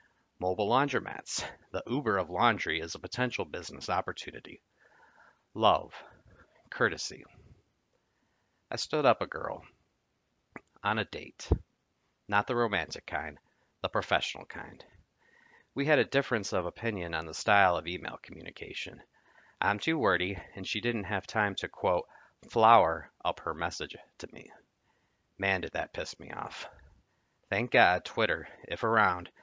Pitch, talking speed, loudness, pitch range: 100 Hz, 135 wpm, -30 LUFS, 90-115 Hz